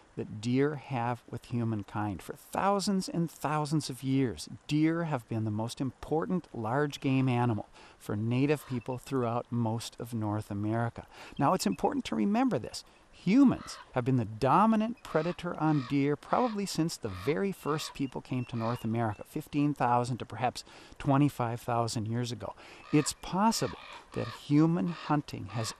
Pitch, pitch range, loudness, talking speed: 130 Hz, 115-155 Hz, -31 LUFS, 150 wpm